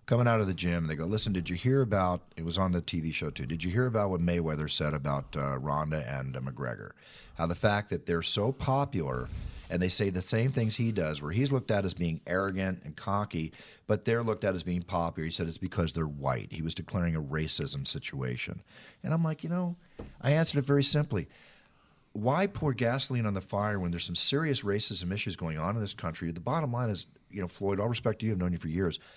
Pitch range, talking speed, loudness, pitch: 85-115 Hz, 245 wpm, -30 LUFS, 95 Hz